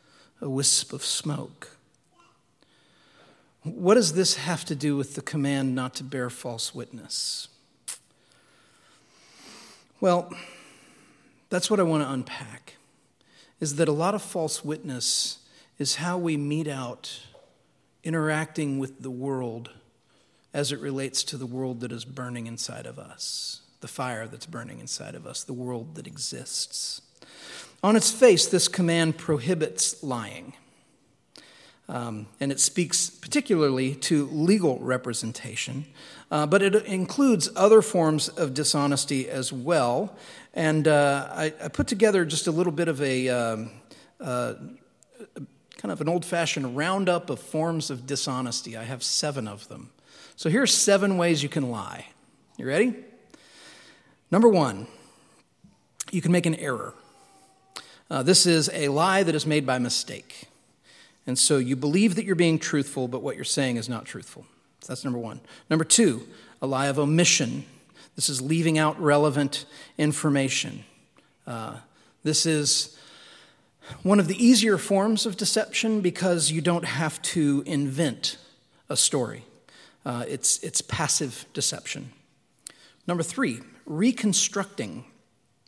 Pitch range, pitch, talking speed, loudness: 135-180 Hz, 155 Hz, 140 wpm, -25 LUFS